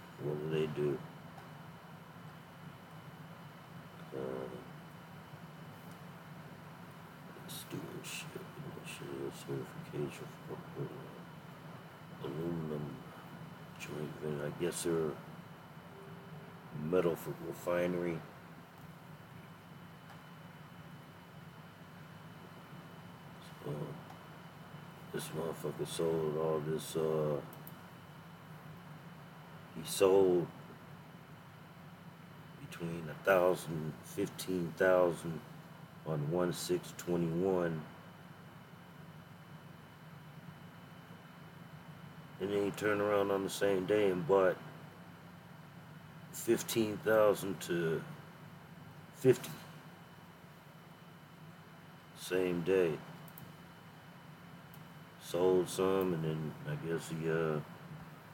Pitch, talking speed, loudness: 155 Hz, 65 wpm, -36 LUFS